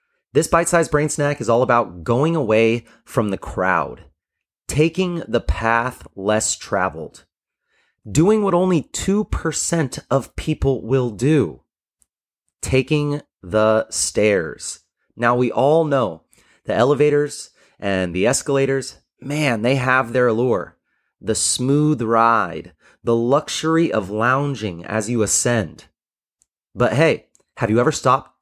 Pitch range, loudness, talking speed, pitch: 110-150 Hz, -19 LUFS, 120 wpm, 130 Hz